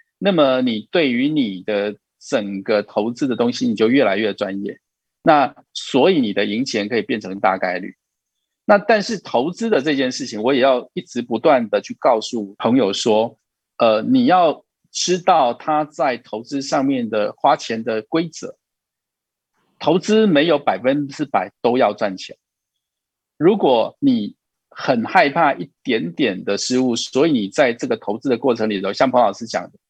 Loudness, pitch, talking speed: -18 LUFS, 150 Hz, 240 characters per minute